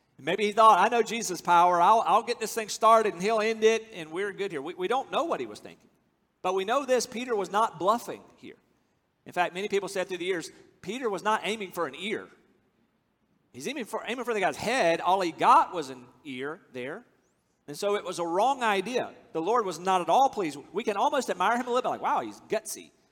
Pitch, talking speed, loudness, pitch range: 215 Hz, 245 wpm, -27 LUFS, 185-235 Hz